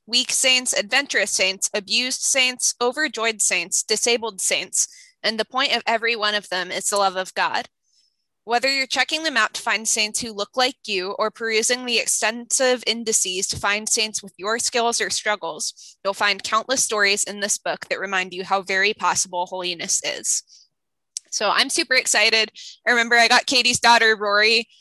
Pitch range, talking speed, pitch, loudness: 200-245 Hz, 180 wpm, 220 Hz, -20 LUFS